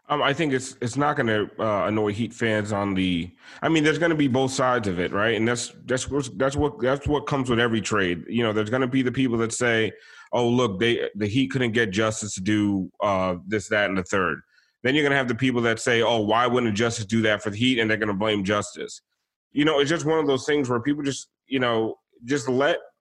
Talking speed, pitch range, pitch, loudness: 265 wpm, 110-135 Hz, 120 Hz, -23 LUFS